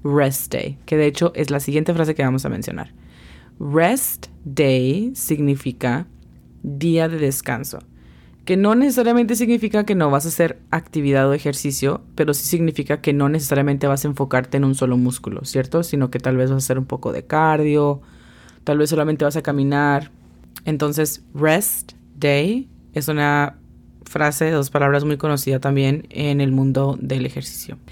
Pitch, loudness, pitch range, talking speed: 145 Hz, -19 LUFS, 130-155 Hz, 170 wpm